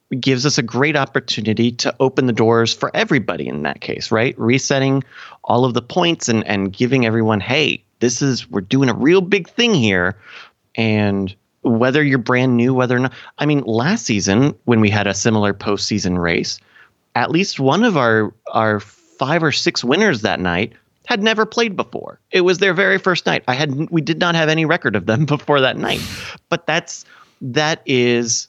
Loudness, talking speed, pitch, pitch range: -17 LUFS, 195 wpm, 125 Hz, 110-150 Hz